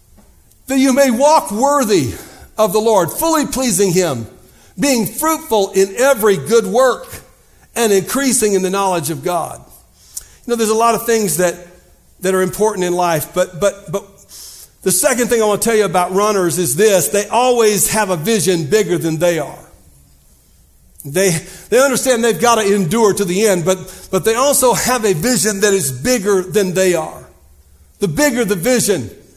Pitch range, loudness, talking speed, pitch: 180-235 Hz, -14 LUFS, 180 wpm, 205 Hz